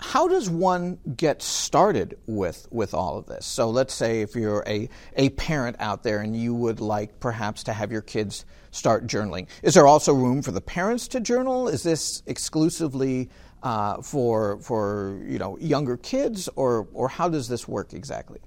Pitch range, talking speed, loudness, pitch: 105-160 Hz, 185 wpm, -24 LUFS, 125 Hz